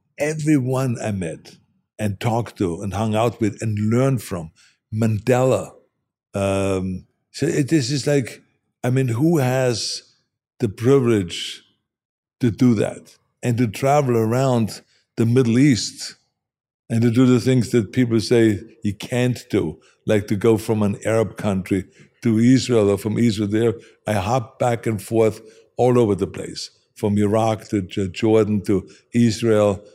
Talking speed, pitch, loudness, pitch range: 150 wpm, 115 Hz, -20 LUFS, 105-125 Hz